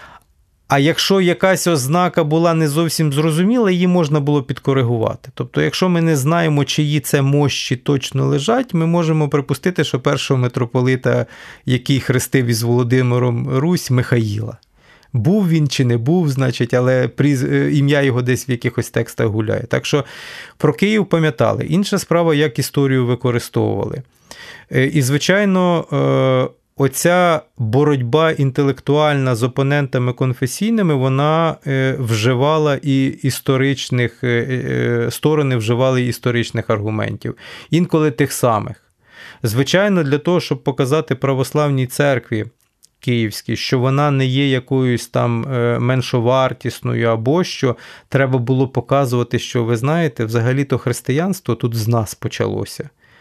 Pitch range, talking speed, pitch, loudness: 125-155 Hz, 120 wpm, 135 Hz, -17 LUFS